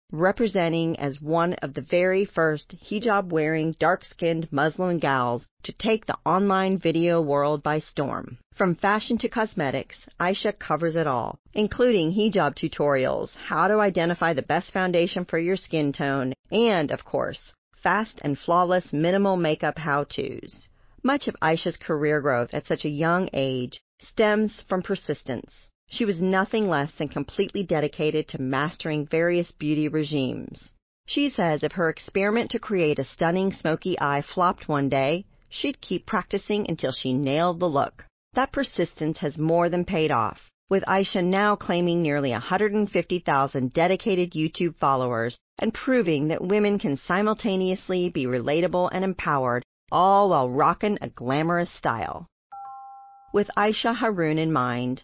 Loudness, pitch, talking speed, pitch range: -24 LUFS, 170 Hz, 145 wpm, 150-195 Hz